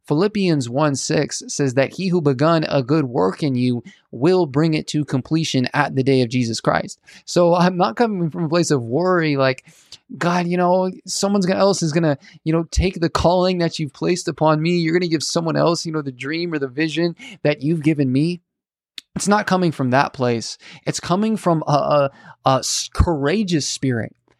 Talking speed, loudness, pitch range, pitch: 200 wpm, -19 LUFS, 145-175 Hz, 160 Hz